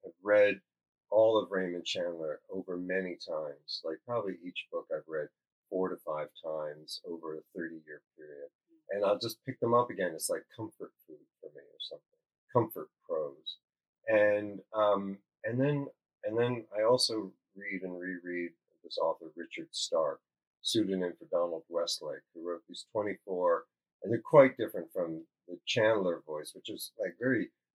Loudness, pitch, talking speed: -33 LUFS, 120 Hz, 160 wpm